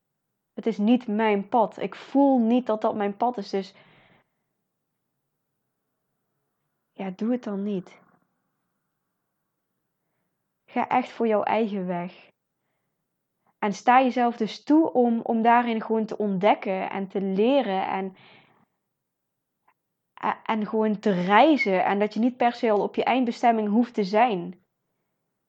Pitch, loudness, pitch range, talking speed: 215 Hz, -24 LUFS, 200-240 Hz, 135 wpm